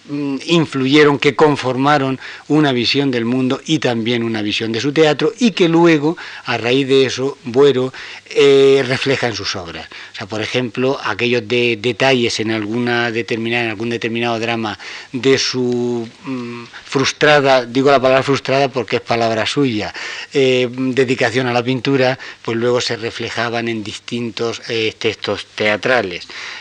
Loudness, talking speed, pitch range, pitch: -16 LUFS, 150 wpm, 115-135 Hz, 125 Hz